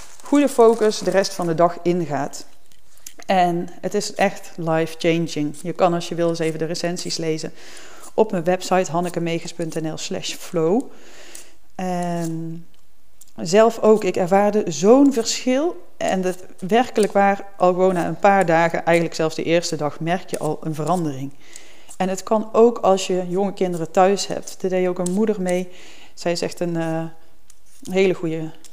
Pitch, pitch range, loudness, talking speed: 180 Hz, 165-200 Hz, -20 LUFS, 165 wpm